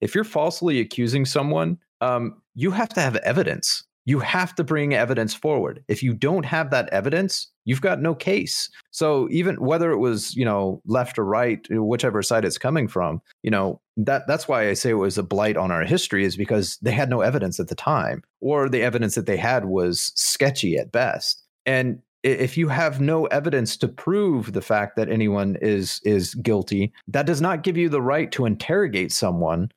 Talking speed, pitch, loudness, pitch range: 200 wpm, 125 Hz, -22 LUFS, 105-155 Hz